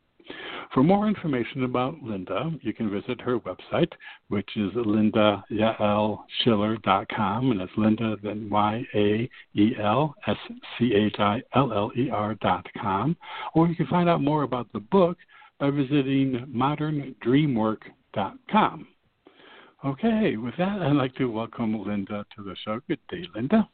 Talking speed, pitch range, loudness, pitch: 145 wpm, 105-145 Hz, -25 LUFS, 120 Hz